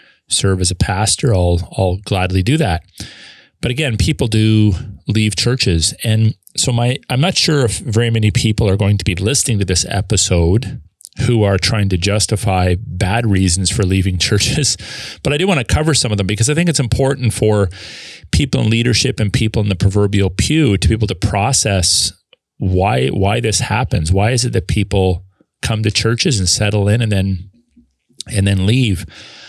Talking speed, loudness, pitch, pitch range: 185 wpm, -15 LUFS, 105 Hz, 95-120 Hz